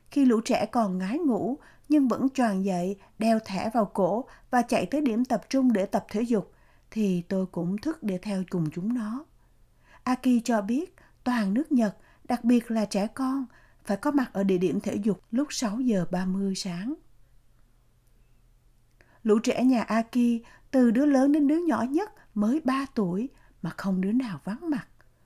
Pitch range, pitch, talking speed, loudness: 190-255 Hz, 225 Hz, 185 wpm, -27 LUFS